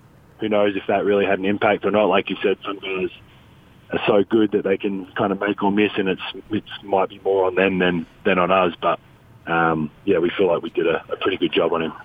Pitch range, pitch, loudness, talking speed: 95-115 Hz, 100 Hz, -21 LUFS, 265 wpm